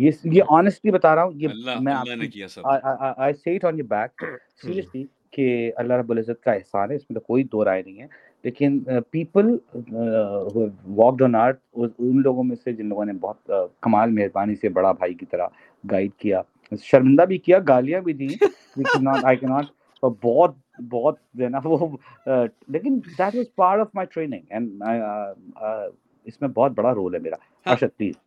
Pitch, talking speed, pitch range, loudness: 130 Hz, 180 wpm, 115-160 Hz, -22 LUFS